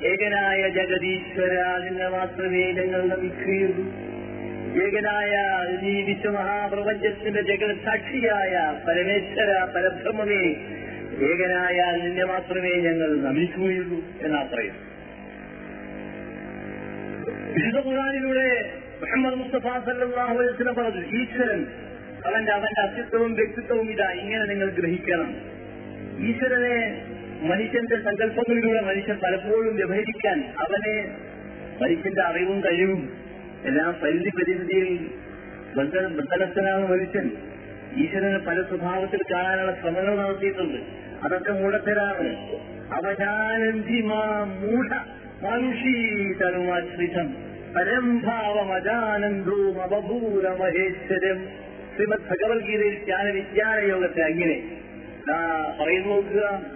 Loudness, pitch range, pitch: -24 LUFS, 185-220 Hz, 195 Hz